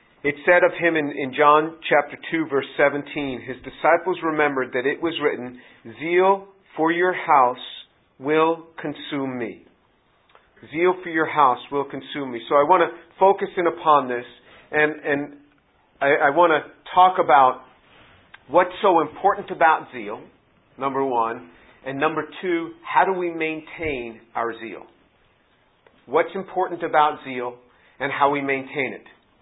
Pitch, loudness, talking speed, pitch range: 150 Hz, -21 LUFS, 150 wpm, 130-165 Hz